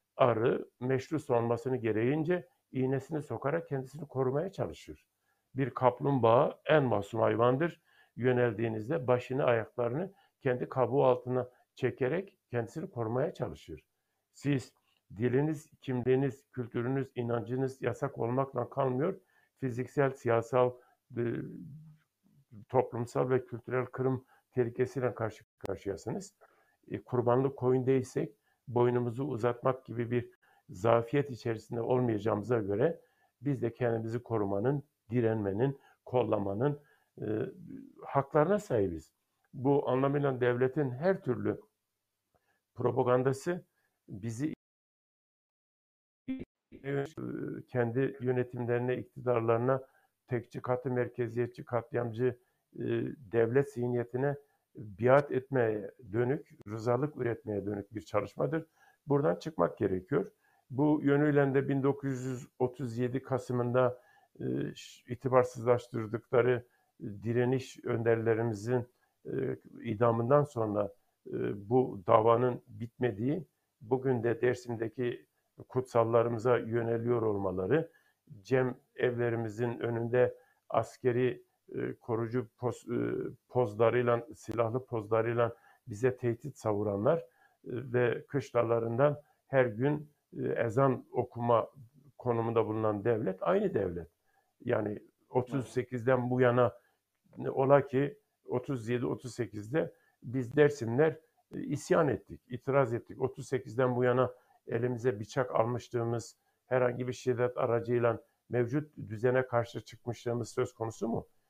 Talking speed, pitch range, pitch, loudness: 85 wpm, 115-135 Hz, 125 Hz, -32 LUFS